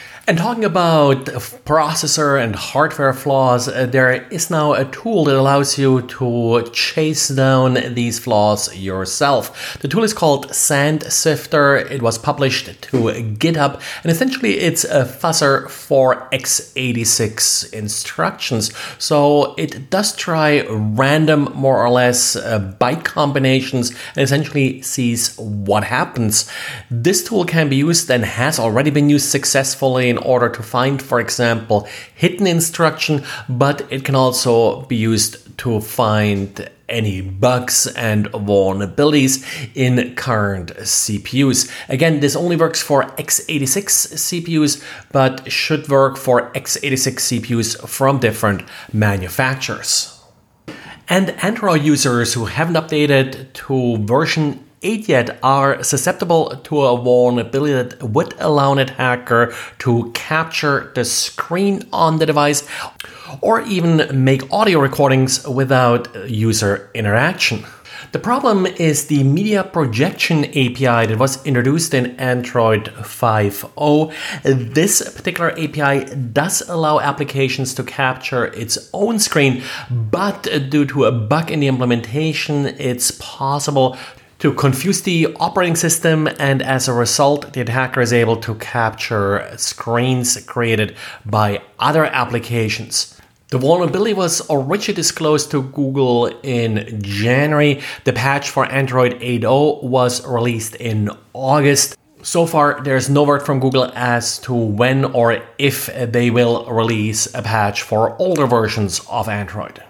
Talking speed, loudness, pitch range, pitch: 130 wpm, -16 LUFS, 120-150 Hz, 135 Hz